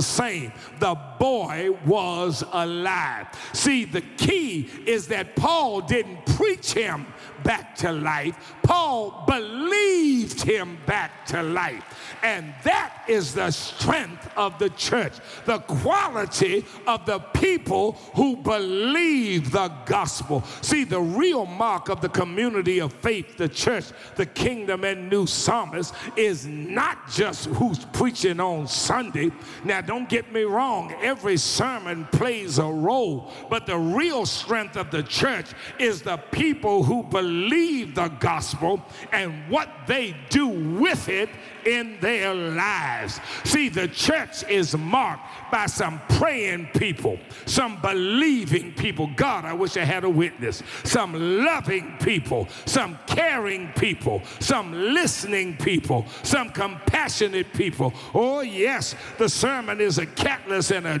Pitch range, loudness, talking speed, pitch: 175-240 Hz, -24 LUFS, 135 wpm, 195 Hz